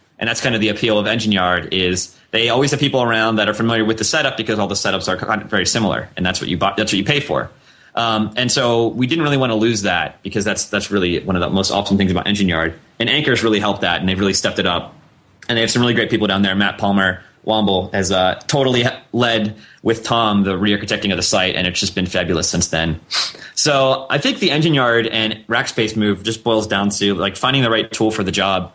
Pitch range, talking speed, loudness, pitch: 95-115 Hz, 255 wpm, -17 LUFS, 110 Hz